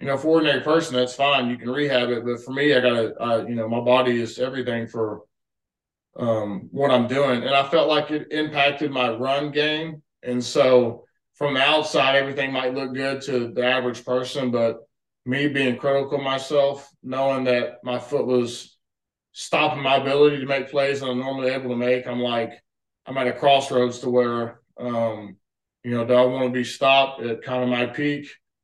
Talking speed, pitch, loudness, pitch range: 200 wpm, 130 Hz, -22 LUFS, 120-140 Hz